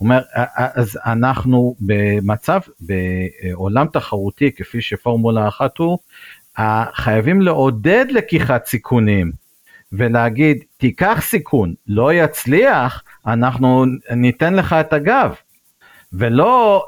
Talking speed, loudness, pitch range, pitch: 90 wpm, -16 LUFS, 110-145 Hz, 125 Hz